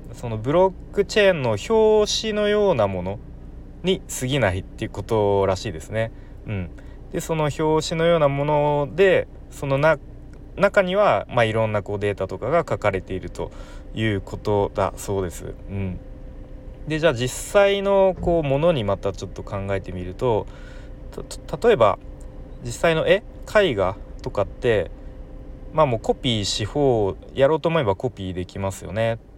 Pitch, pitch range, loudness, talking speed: 115 Hz, 100-160 Hz, -22 LUFS, 310 characters per minute